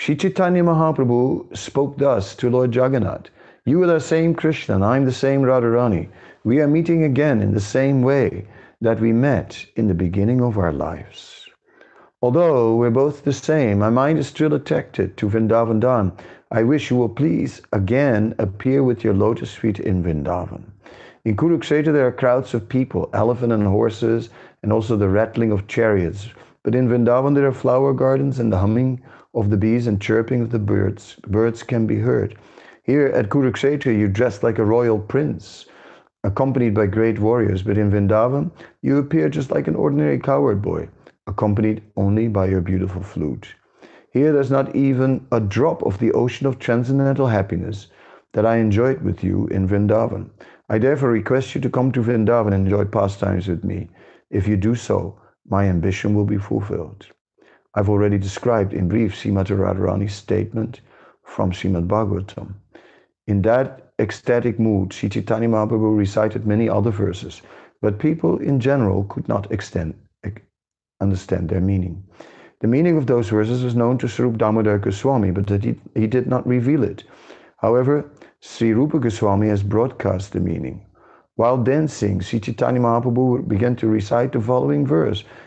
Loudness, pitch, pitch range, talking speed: -19 LUFS, 115 Hz, 100-130 Hz, 170 wpm